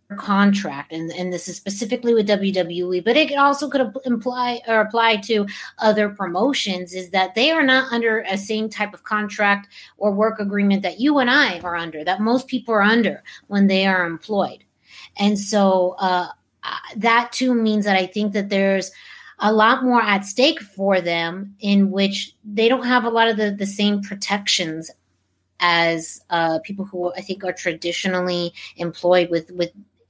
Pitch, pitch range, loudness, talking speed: 200 Hz, 180-225 Hz, -19 LUFS, 175 wpm